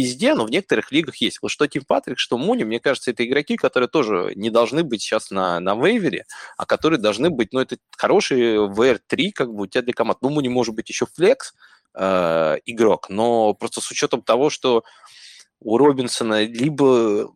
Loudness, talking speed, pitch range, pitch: -20 LUFS, 195 wpm, 110-130 Hz, 120 Hz